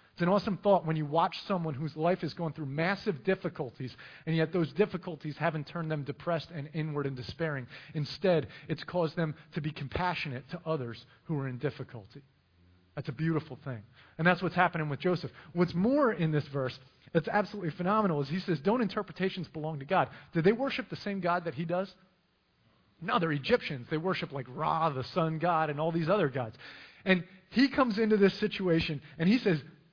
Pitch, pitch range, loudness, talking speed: 165 Hz, 145-185 Hz, -31 LUFS, 200 wpm